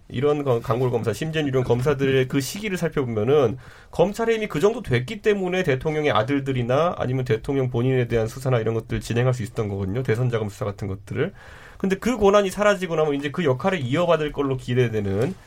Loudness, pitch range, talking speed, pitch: -23 LUFS, 120-165 Hz, 450 characters per minute, 135 Hz